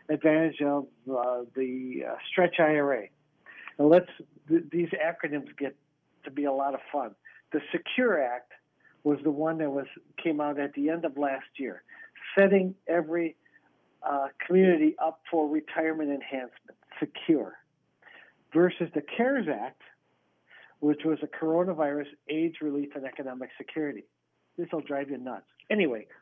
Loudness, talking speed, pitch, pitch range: -29 LUFS, 140 wpm, 150 Hz, 140-165 Hz